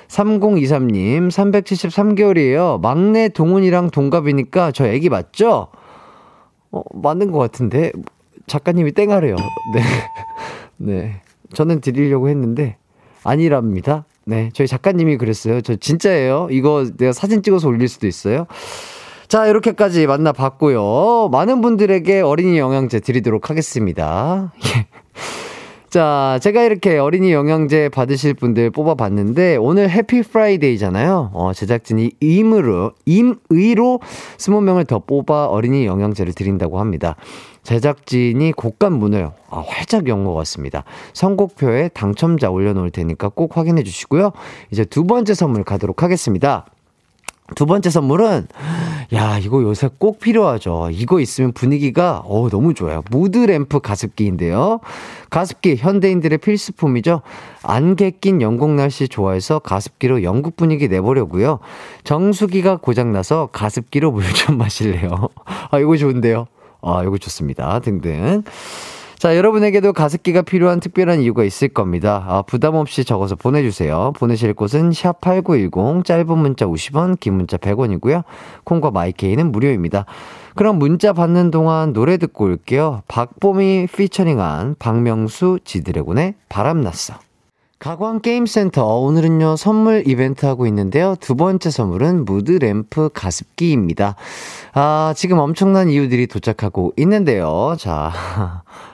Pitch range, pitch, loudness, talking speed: 110-180 Hz, 145 Hz, -16 LUFS, 310 characters per minute